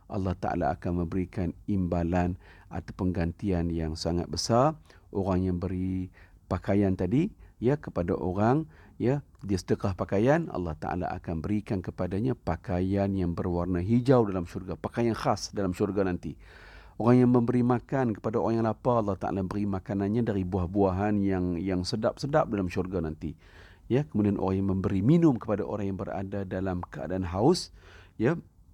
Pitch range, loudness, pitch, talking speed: 90-110 Hz, -28 LUFS, 95 Hz, 150 wpm